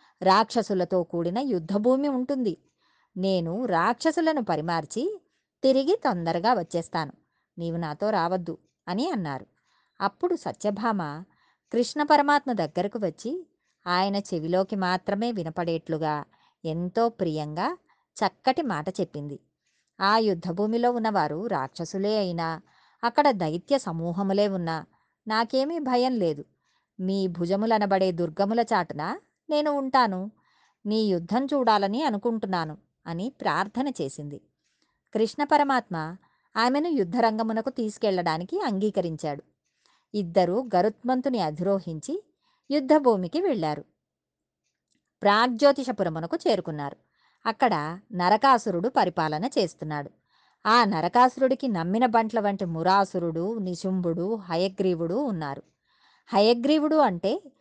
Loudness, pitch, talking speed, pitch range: -26 LUFS, 200 Hz, 85 wpm, 170-250 Hz